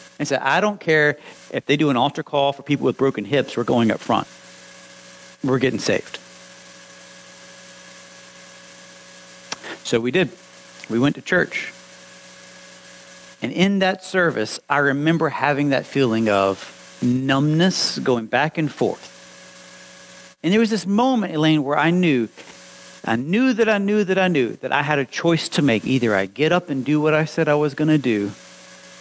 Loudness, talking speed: -20 LUFS, 170 wpm